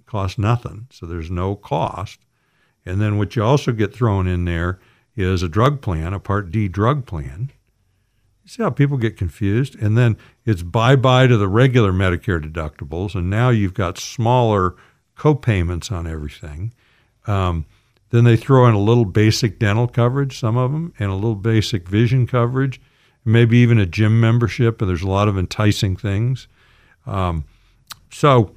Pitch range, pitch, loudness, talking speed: 95-125 Hz, 110 Hz, -18 LUFS, 170 wpm